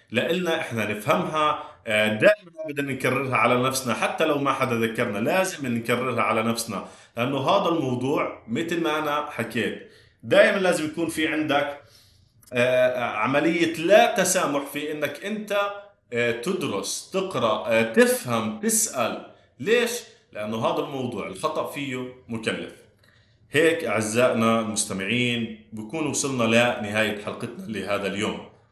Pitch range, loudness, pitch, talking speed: 115-160 Hz, -24 LUFS, 130 Hz, 115 wpm